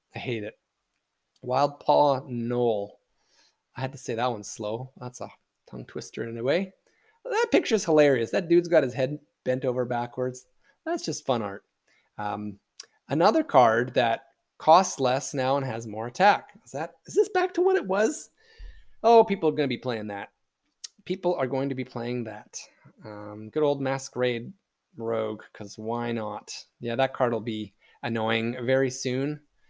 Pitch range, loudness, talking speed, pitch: 115-150 Hz, -26 LUFS, 175 wpm, 130 Hz